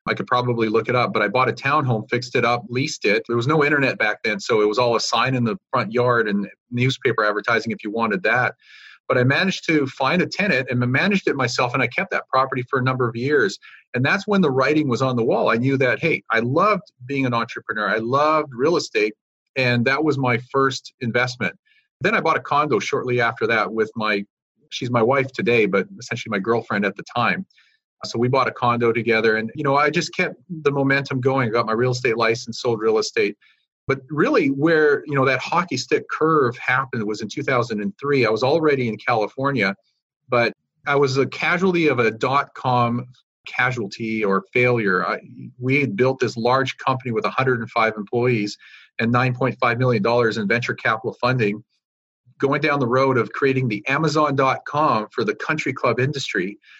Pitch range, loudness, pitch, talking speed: 120-140 Hz, -20 LUFS, 130 Hz, 205 wpm